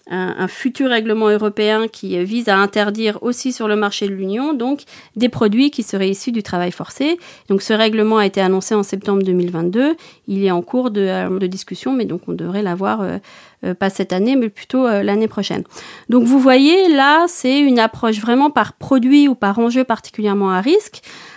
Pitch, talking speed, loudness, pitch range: 215 Hz, 195 wpm, -16 LUFS, 195-255 Hz